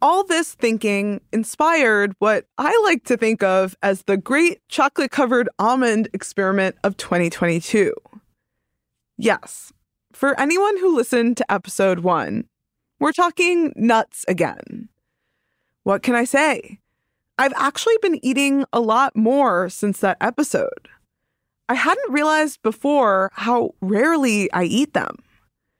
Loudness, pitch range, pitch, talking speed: -19 LUFS, 200-295 Hz, 240 Hz, 125 wpm